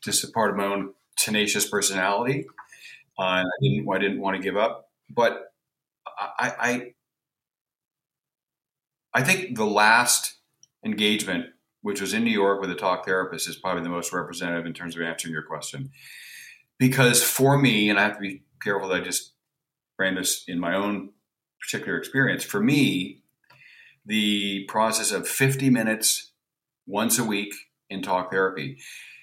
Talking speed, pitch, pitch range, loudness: 155 wpm, 100 Hz, 95-120 Hz, -24 LUFS